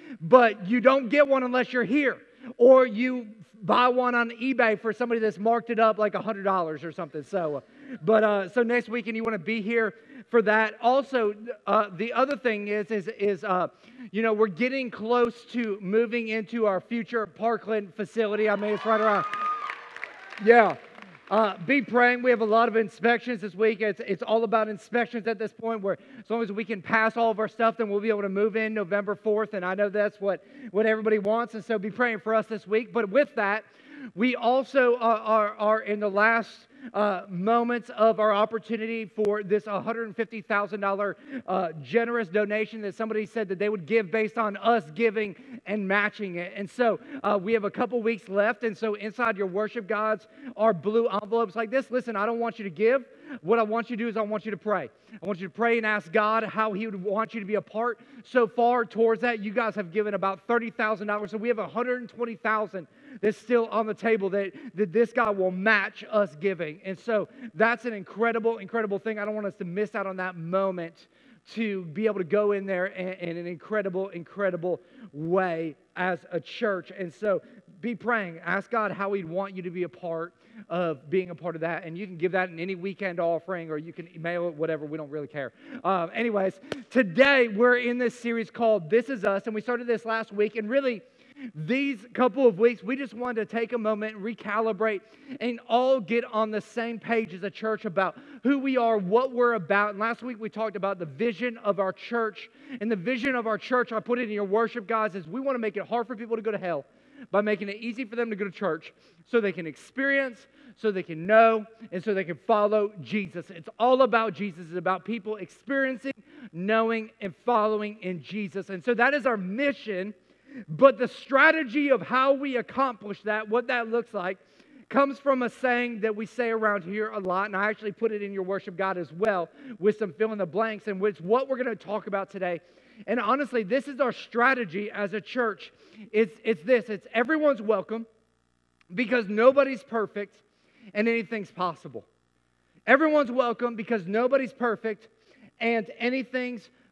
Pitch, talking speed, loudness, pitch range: 220 Hz, 210 wpm, -26 LUFS, 205-240 Hz